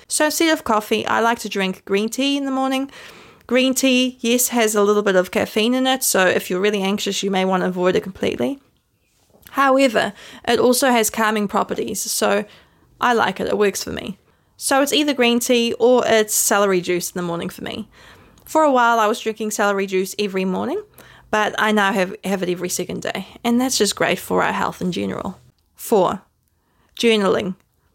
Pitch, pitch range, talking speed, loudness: 220 Hz, 200-250 Hz, 200 wpm, -19 LUFS